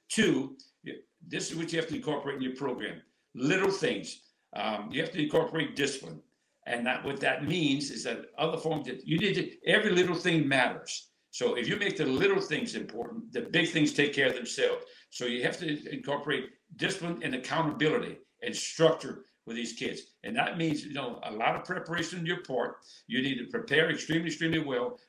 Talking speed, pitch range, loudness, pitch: 200 wpm, 145-175 Hz, -30 LUFS, 160 Hz